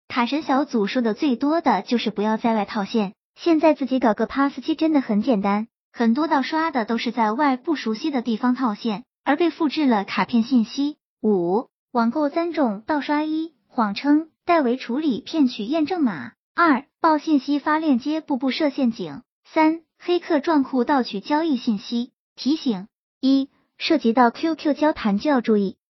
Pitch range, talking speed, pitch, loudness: 230-305 Hz, 265 characters per minute, 265 Hz, -22 LUFS